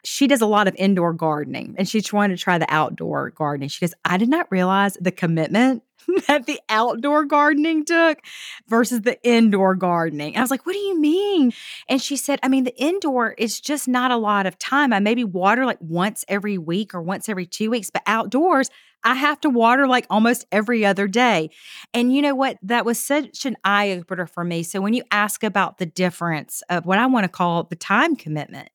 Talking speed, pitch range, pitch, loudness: 220 wpm, 185-265 Hz, 220 Hz, -20 LUFS